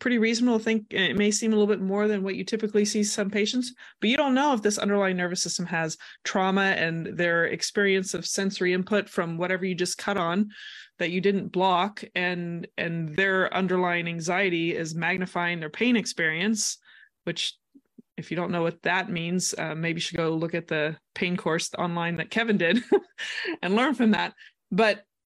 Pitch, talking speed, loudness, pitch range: 190 Hz, 195 wpm, -26 LUFS, 175-215 Hz